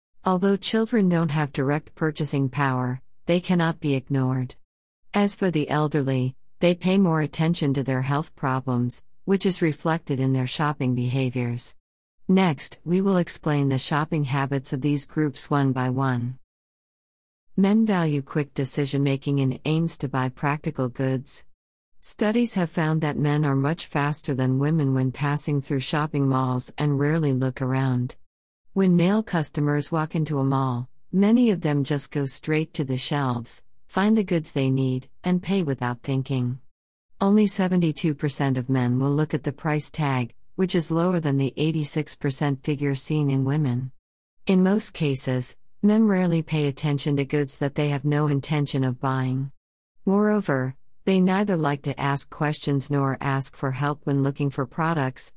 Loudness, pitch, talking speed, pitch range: -24 LUFS, 145 Hz, 160 wpm, 130-160 Hz